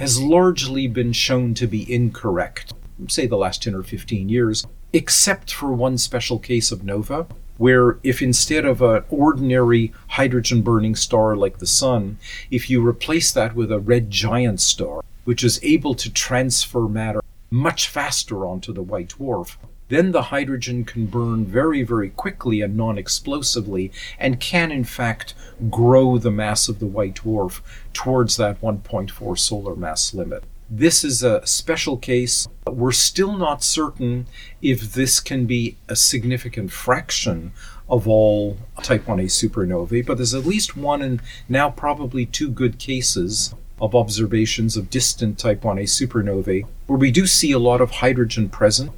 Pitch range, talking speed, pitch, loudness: 110-130 Hz, 160 wpm, 120 Hz, -19 LUFS